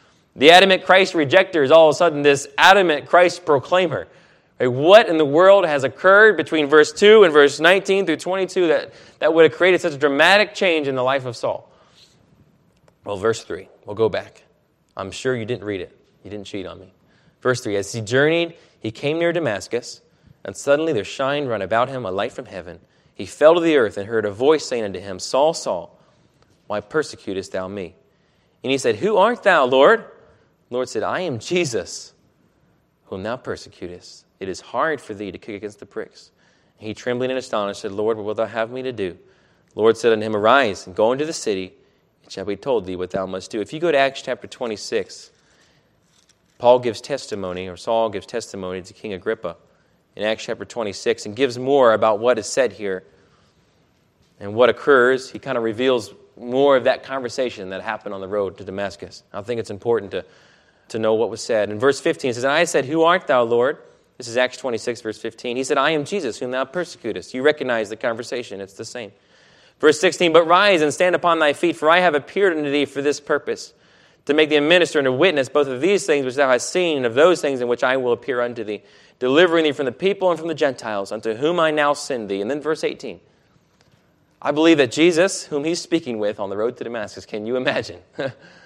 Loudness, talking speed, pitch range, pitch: -19 LUFS, 220 wpm, 110-170 Hz, 140 Hz